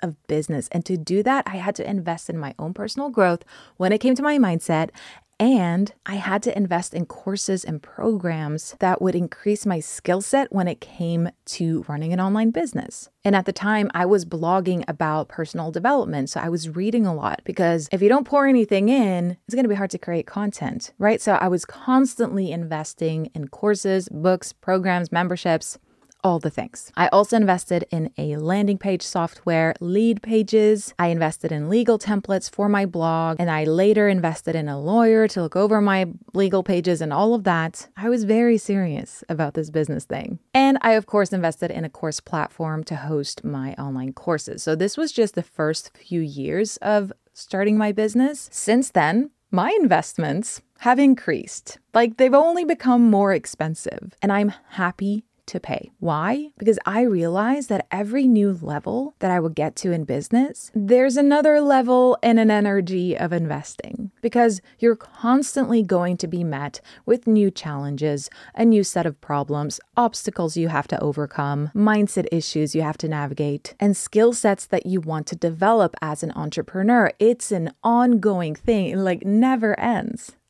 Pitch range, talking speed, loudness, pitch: 165-225 Hz, 180 wpm, -21 LUFS, 190 Hz